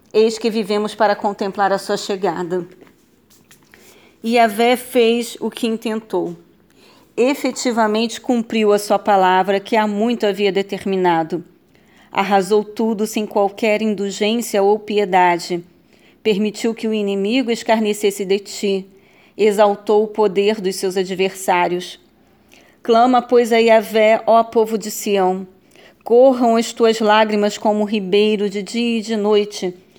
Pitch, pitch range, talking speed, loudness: 210 Hz, 200-225 Hz, 130 wpm, -17 LUFS